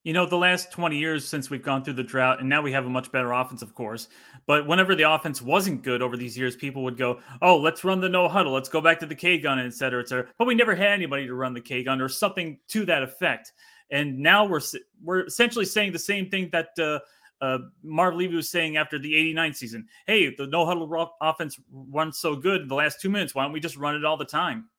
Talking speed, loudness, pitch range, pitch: 260 wpm, -24 LUFS, 135-180 Hz, 155 Hz